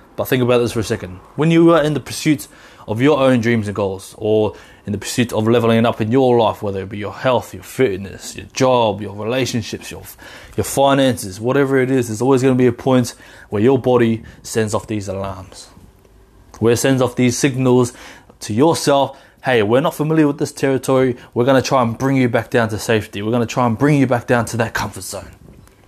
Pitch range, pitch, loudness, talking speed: 110-135 Hz, 120 Hz, -17 LUFS, 230 wpm